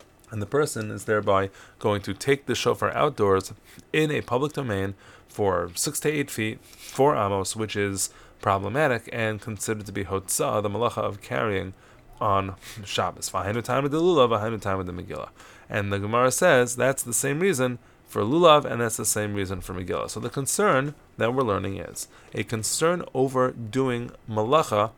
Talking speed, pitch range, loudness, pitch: 185 wpm, 100-130 Hz, -25 LUFS, 110 Hz